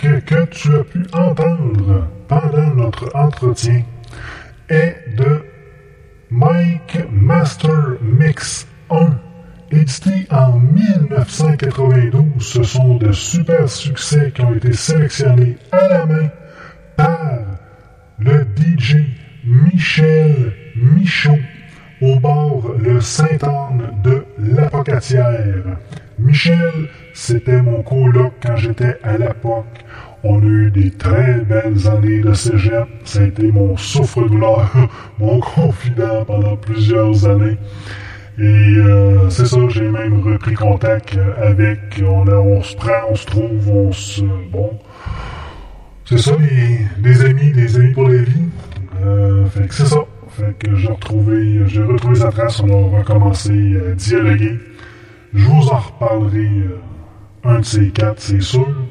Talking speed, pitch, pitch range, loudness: 125 wpm, 120 Hz, 105-145 Hz, -14 LUFS